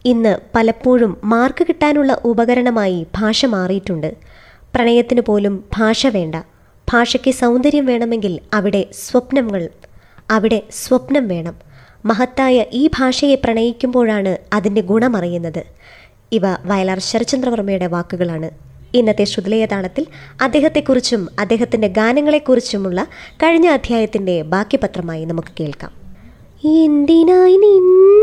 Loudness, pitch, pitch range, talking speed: -15 LUFS, 230 Hz, 195-260 Hz, 85 wpm